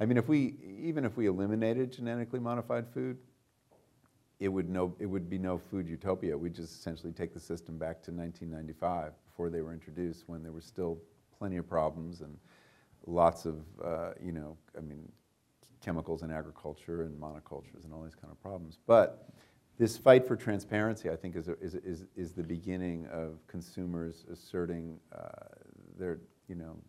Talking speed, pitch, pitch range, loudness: 175 wpm, 85 Hz, 80-105 Hz, -35 LUFS